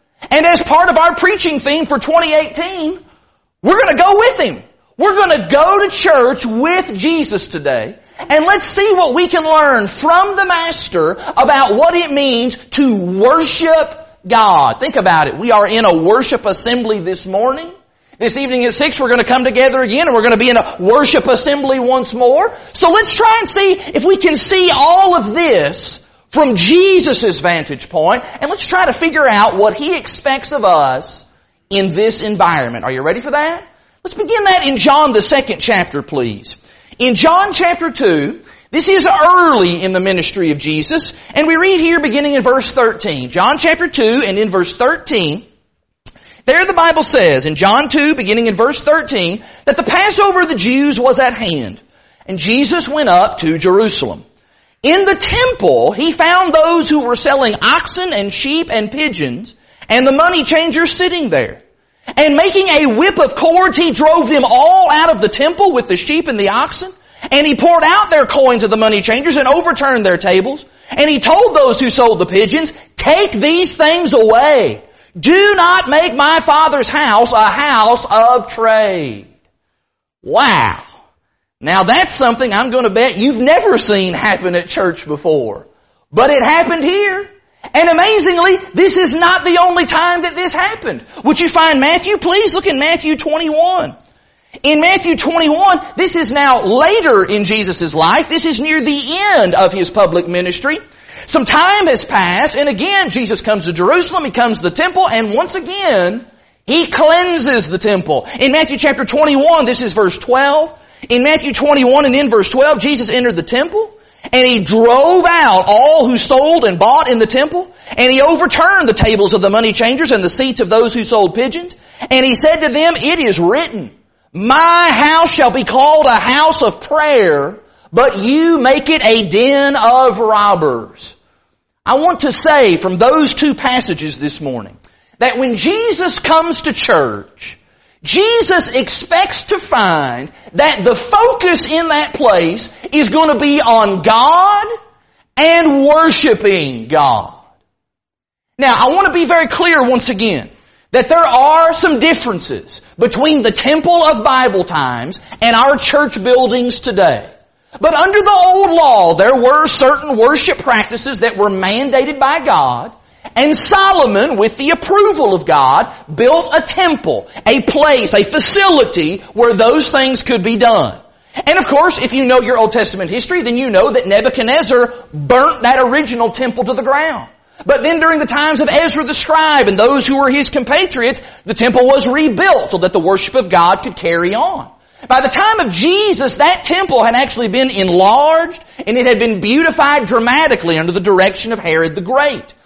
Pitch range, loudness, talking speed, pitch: 235-330 Hz, -10 LUFS, 175 wpm, 285 Hz